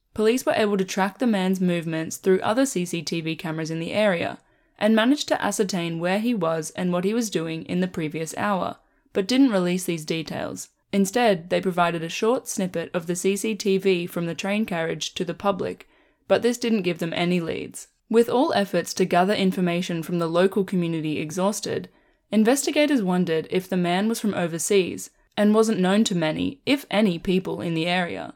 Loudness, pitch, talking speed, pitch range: -23 LUFS, 185 Hz, 190 wpm, 170-215 Hz